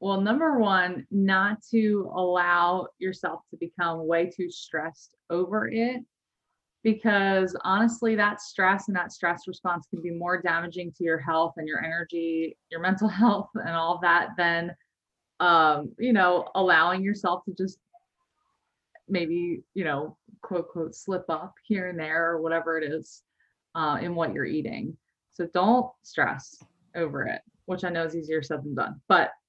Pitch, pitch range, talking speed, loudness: 180 Hz, 170-205 Hz, 160 wpm, -26 LUFS